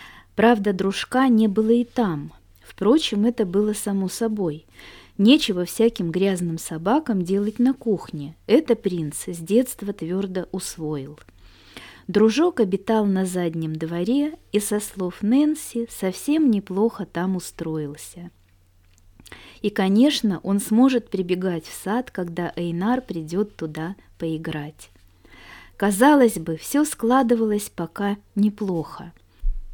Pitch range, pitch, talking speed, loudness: 165-225 Hz, 195 Hz, 110 wpm, -22 LUFS